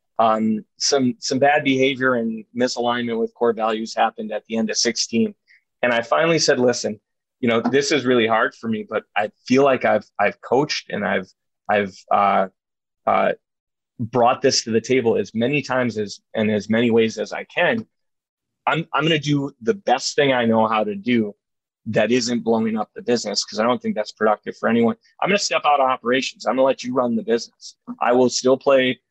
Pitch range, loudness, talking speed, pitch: 110-130 Hz, -20 LUFS, 210 wpm, 120 Hz